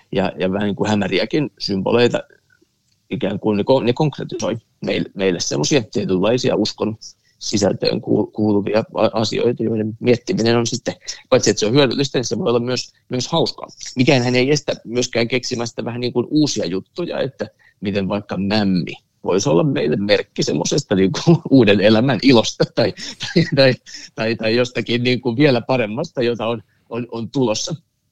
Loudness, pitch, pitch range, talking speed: -18 LUFS, 120 Hz, 105-125 Hz, 165 wpm